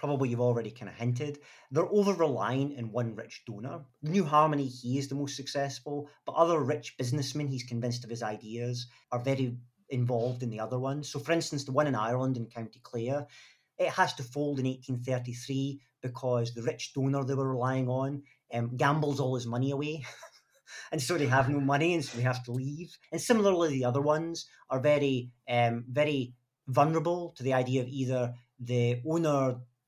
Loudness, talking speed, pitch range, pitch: -31 LUFS, 190 wpm, 125-145 Hz, 135 Hz